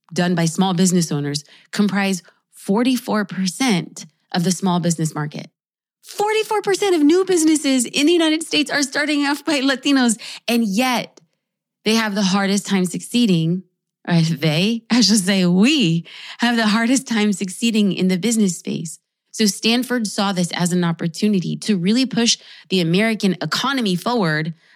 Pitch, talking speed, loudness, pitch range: 210 Hz, 150 wpm, -18 LUFS, 180-245 Hz